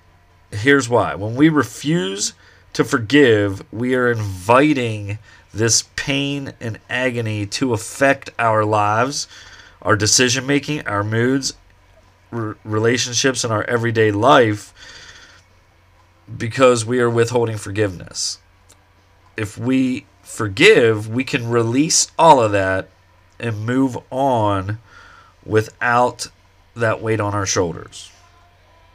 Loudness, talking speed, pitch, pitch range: -17 LUFS, 110 wpm, 110 Hz, 100-125 Hz